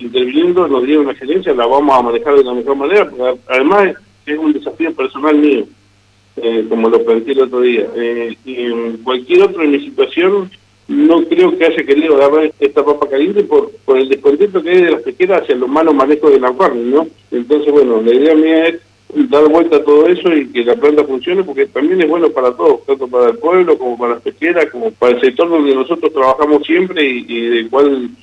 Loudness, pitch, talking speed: -12 LUFS, 165 Hz, 220 wpm